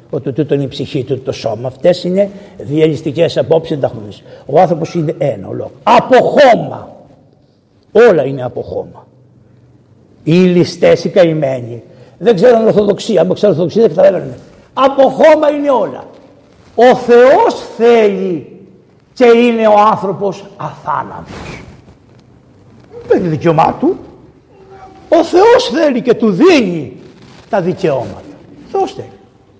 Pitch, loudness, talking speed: 205 Hz, -11 LUFS, 130 wpm